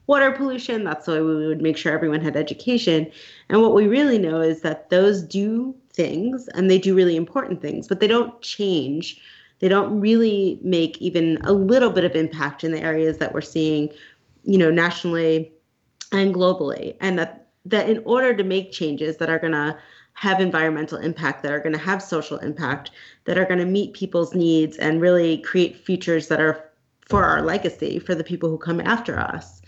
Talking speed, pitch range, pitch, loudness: 195 wpm, 155-195 Hz, 170 Hz, -21 LUFS